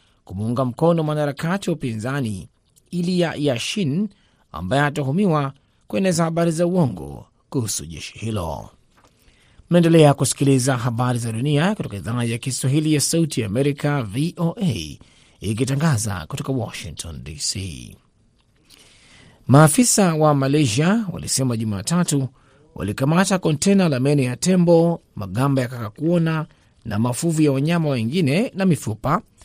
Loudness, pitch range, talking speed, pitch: -20 LUFS, 120-170 Hz, 105 wpm, 145 Hz